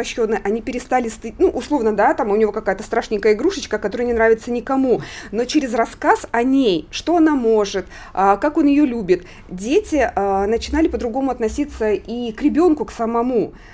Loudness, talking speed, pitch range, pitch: -18 LUFS, 160 wpm, 220-285 Hz, 235 Hz